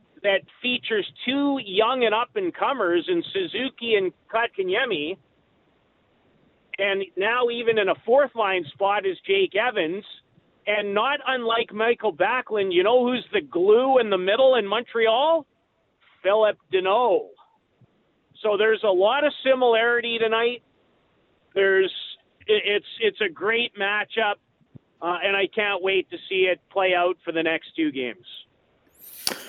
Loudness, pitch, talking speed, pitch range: -23 LUFS, 230 Hz, 130 wpm, 200-300 Hz